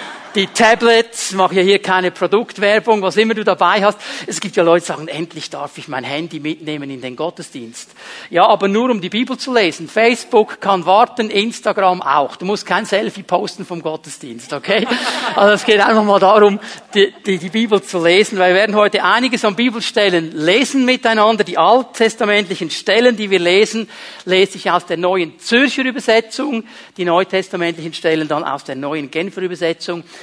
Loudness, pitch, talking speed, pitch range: -15 LUFS, 195 Hz, 180 wpm, 175-220 Hz